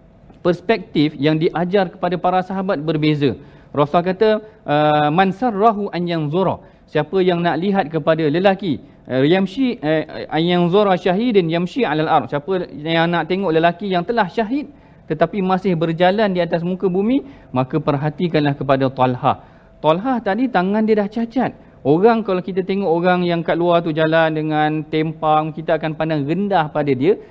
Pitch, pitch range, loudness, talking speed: 175 Hz, 155-195 Hz, -18 LUFS, 160 wpm